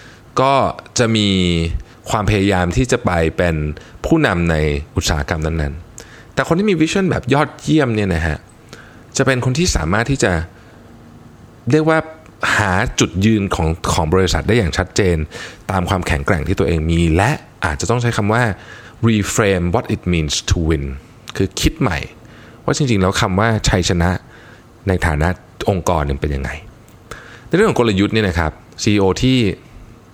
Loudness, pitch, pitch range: -17 LUFS, 100 Hz, 85-120 Hz